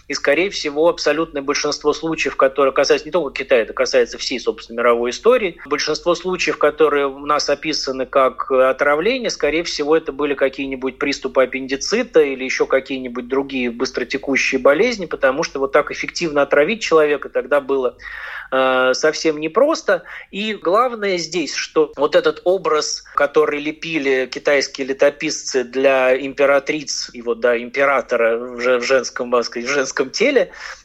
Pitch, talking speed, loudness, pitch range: 145 Hz, 140 wpm, -18 LUFS, 130-160 Hz